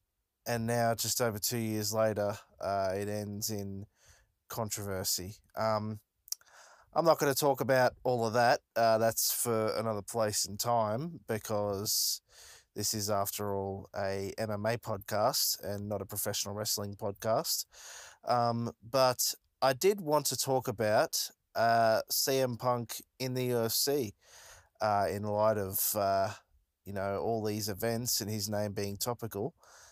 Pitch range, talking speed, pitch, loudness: 100-120 Hz, 145 wpm, 110 Hz, -32 LUFS